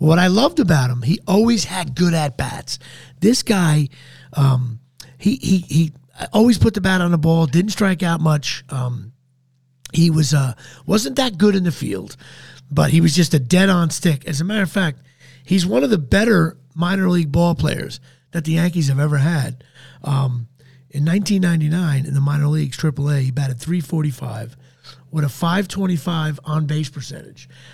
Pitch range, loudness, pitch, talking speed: 135-175 Hz, -18 LUFS, 155 Hz, 180 wpm